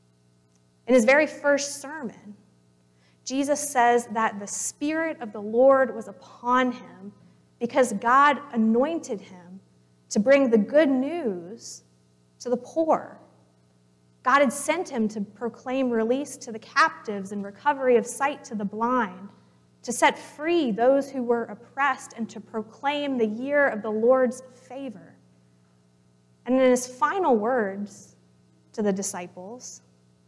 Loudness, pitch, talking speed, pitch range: -24 LUFS, 230 Hz, 135 wpm, 180-270 Hz